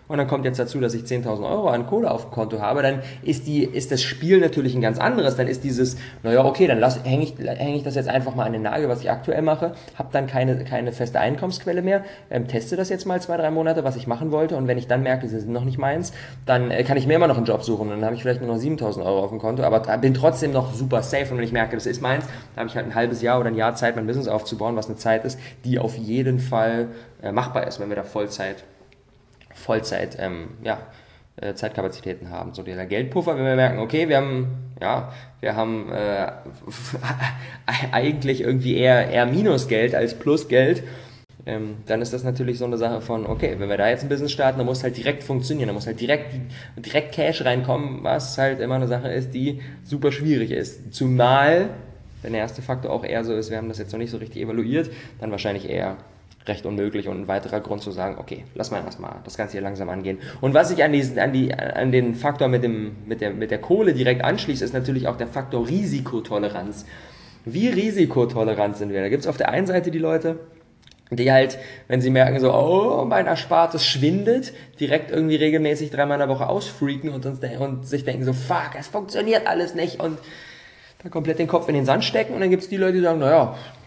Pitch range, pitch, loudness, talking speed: 115-140 Hz, 130 Hz, -22 LUFS, 230 wpm